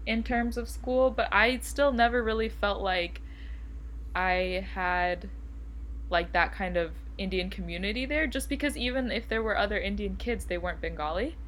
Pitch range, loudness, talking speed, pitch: 170-235 Hz, -29 LUFS, 165 wpm, 195 Hz